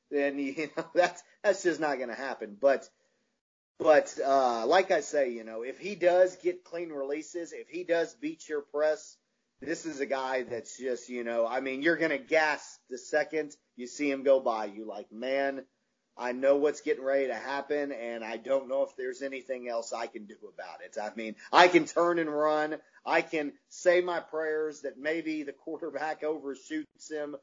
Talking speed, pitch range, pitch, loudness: 195 wpm, 135-165 Hz, 150 Hz, -30 LUFS